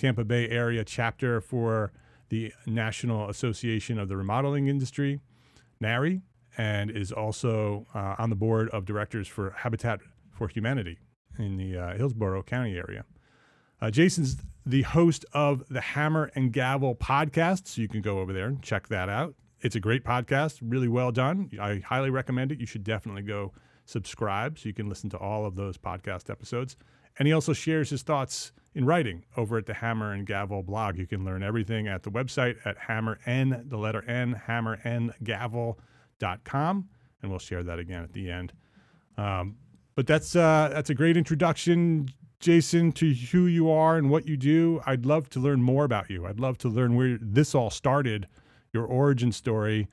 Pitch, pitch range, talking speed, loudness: 120 Hz, 105-140 Hz, 180 wpm, -28 LUFS